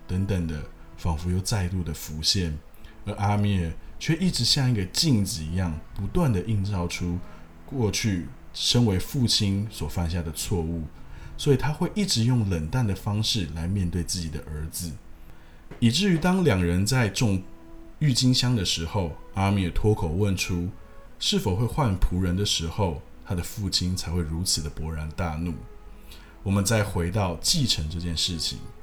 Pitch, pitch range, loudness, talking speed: 90 Hz, 85-110 Hz, -26 LUFS, 245 characters per minute